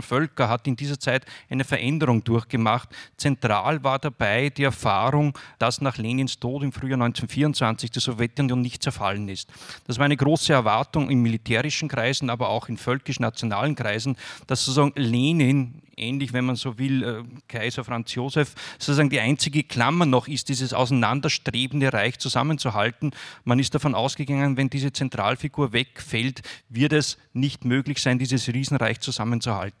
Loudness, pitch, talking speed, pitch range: -24 LUFS, 130 Hz, 150 wpm, 120-140 Hz